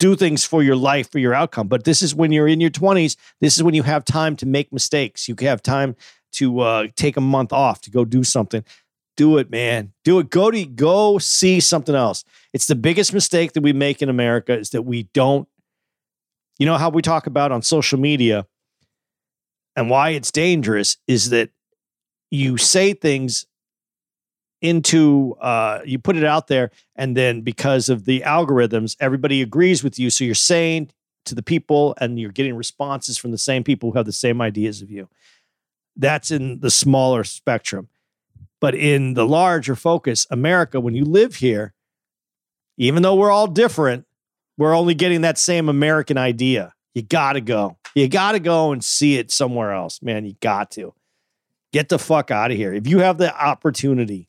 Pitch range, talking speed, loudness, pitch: 125-160 Hz, 190 wpm, -18 LUFS, 140 Hz